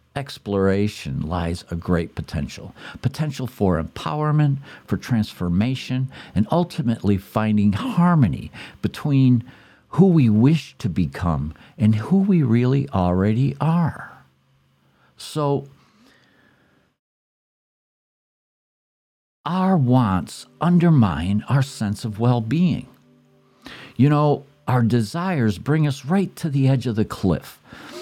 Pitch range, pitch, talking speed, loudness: 100-145 Hz, 125 Hz, 105 wpm, -21 LUFS